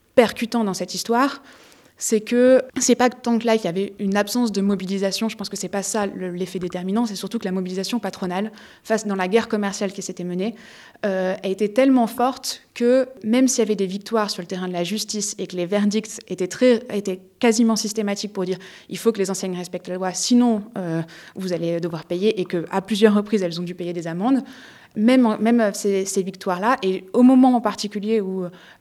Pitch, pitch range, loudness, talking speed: 205 Hz, 185-230 Hz, -21 LUFS, 215 wpm